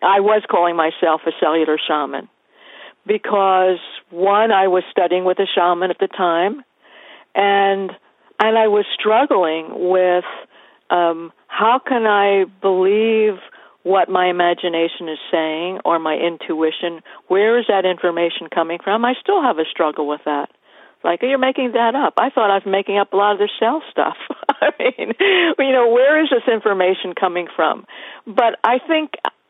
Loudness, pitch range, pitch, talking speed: -17 LUFS, 175-225 Hz, 195 Hz, 165 wpm